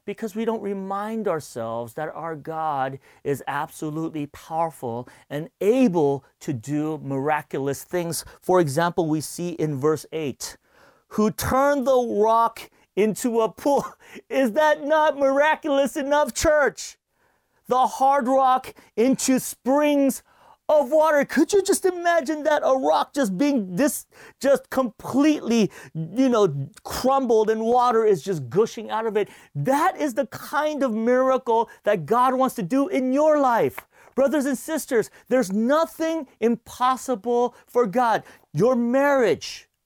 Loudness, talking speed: -22 LUFS, 135 wpm